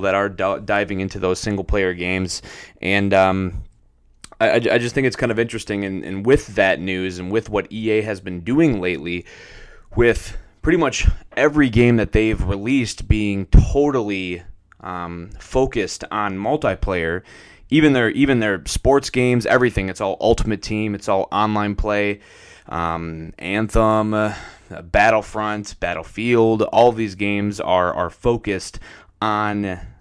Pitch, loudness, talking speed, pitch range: 100 Hz, -19 LUFS, 140 wpm, 95-110 Hz